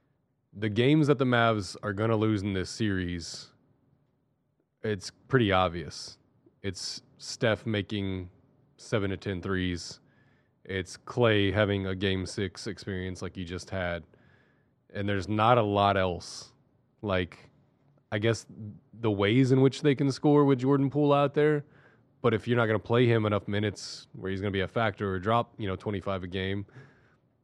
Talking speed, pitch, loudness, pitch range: 170 wpm, 110 Hz, -28 LUFS, 95-130 Hz